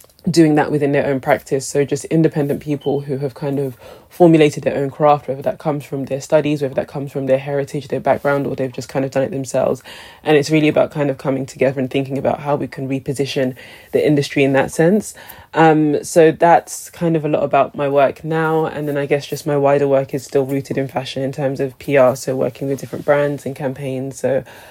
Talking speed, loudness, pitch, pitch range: 235 wpm, -17 LUFS, 140 Hz, 135-150 Hz